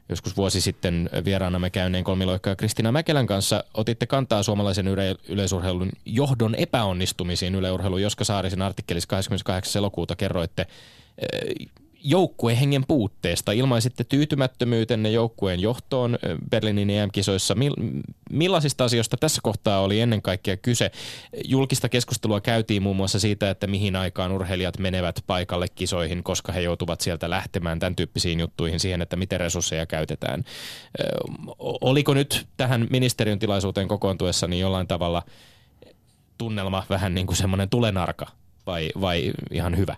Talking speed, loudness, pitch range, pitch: 130 wpm, -24 LUFS, 95-115 Hz, 100 Hz